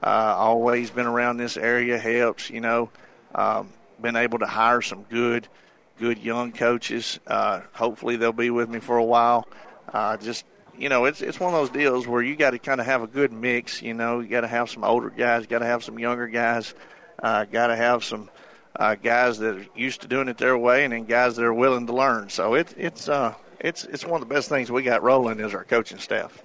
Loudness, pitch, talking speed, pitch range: -23 LUFS, 120 Hz, 225 wpm, 115-125 Hz